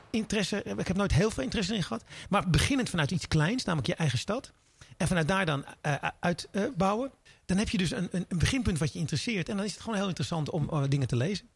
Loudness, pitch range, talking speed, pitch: -30 LUFS, 155-205 Hz, 245 wpm, 180 Hz